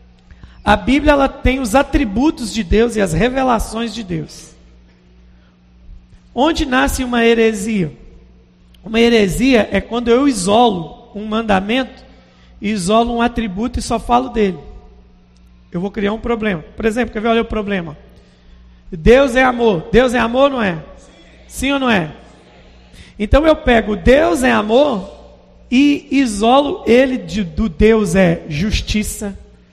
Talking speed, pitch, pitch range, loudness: 140 wpm, 225 Hz, 175-250 Hz, -15 LUFS